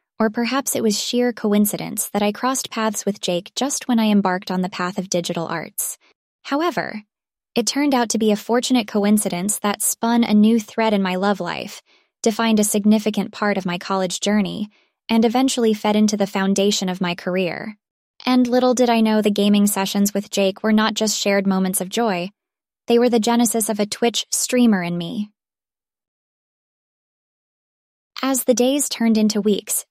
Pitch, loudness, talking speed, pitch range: 215 Hz, -19 LUFS, 180 wpm, 200-235 Hz